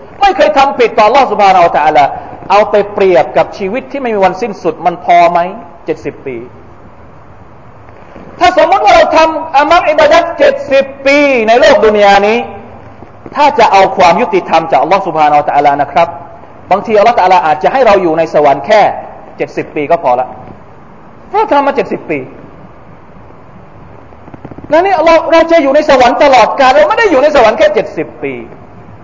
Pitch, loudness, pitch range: 230 Hz, -8 LUFS, 180-295 Hz